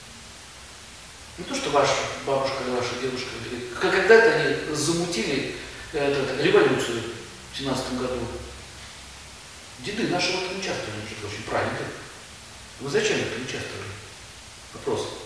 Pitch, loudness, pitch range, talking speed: 135 Hz, -25 LUFS, 120-175 Hz, 105 wpm